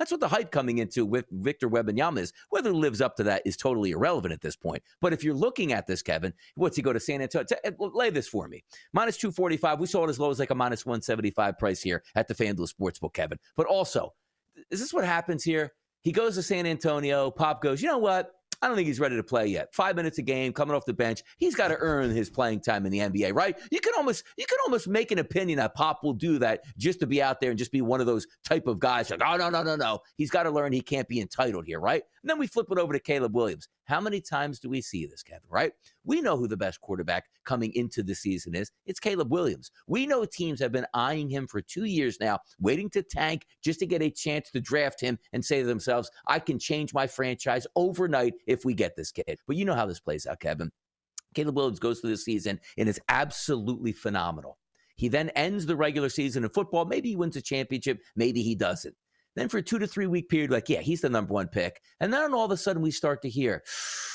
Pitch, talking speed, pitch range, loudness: 145 Hz, 260 wpm, 120-175 Hz, -28 LUFS